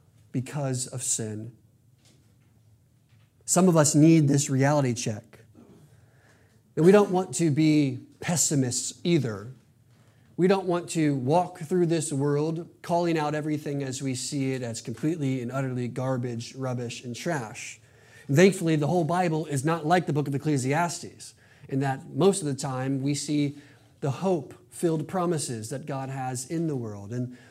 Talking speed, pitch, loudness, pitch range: 155 wpm, 135 Hz, -26 LUFS, 125-160 Hz